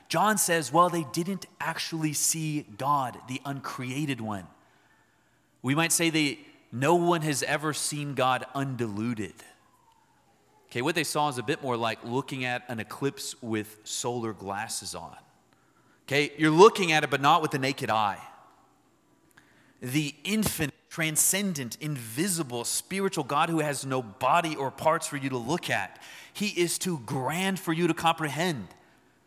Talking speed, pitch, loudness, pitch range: 155 wpm, 150 Hz, -27 LUFS, 130-165 Hz